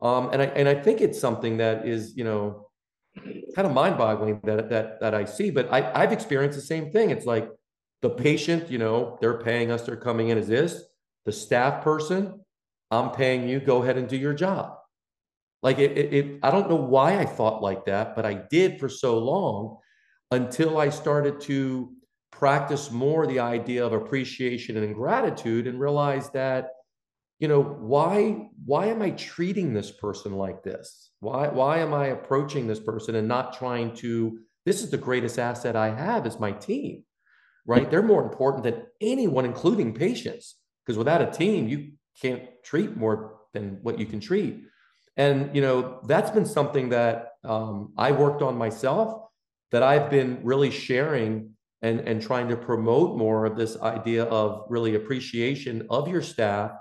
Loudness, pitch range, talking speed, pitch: -25 LUFS, 115-140 Hz, 180 wpm, 125 Hz